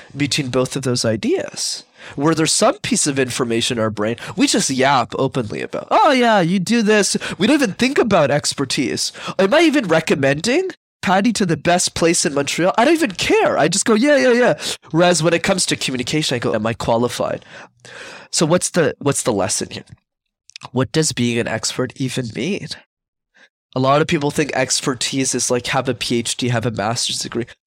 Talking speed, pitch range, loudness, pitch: 195 wpm, 125-190 Hz, -17 LUFS, 145 Hz